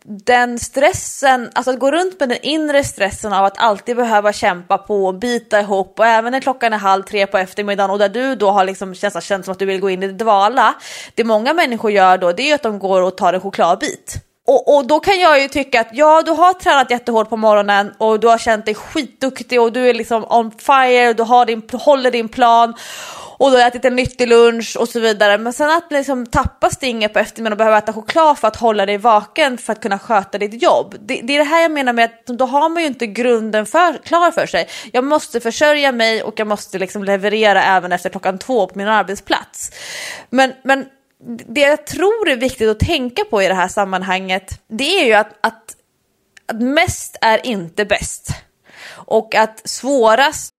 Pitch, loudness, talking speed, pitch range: 230 Hz, -15 LUFS, 220 wpm, 205-265 Hz